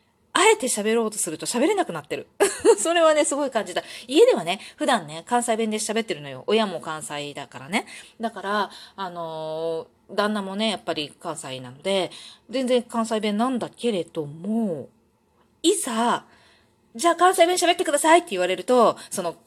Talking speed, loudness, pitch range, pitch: 335 characters per minute, -23 LUFS, 170-255 Hz, 215 Hz